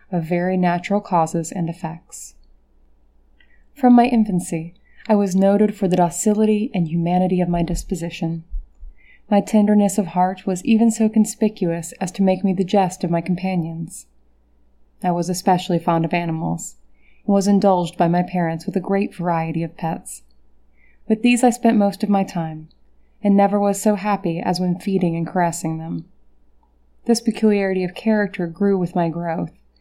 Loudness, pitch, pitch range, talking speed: -19 LUFS, 180 Hz, 165-200 Hz, 165 wpm